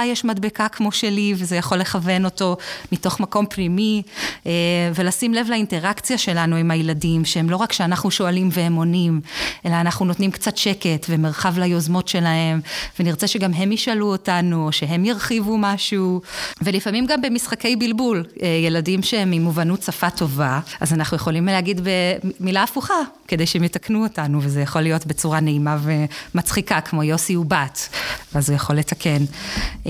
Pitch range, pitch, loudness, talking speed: 165-205 Hz, 180 Hz, -20 LUFS, 150 wpm